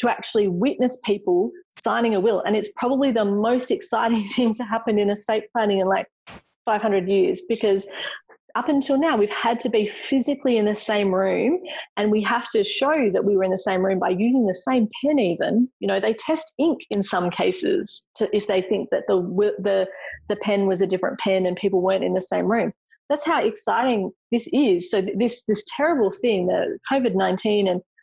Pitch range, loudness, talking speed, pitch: 195-255 Hz, -22 LUFS, 210 wpm, 215 Hz